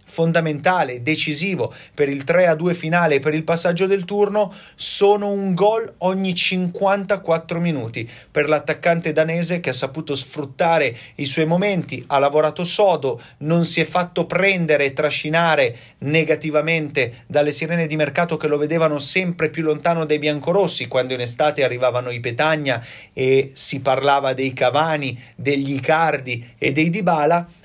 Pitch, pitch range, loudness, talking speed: 155 Hz, 140-175 Hz, -19 LUFS, 145 wpm